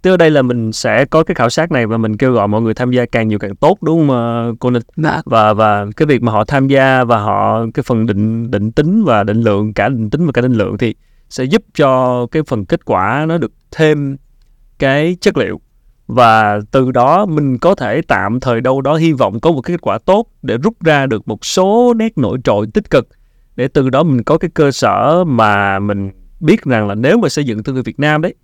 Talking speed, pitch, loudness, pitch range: 250 wpm, 125 Hz, -13 LUFS, 110-155 Hz